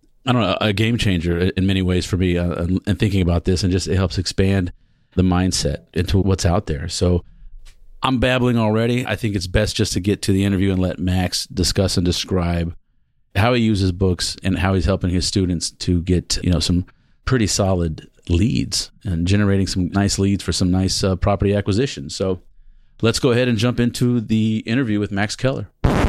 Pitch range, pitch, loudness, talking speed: 90-110 Hz, 95 Hz, -19 LUFS, 200 wpm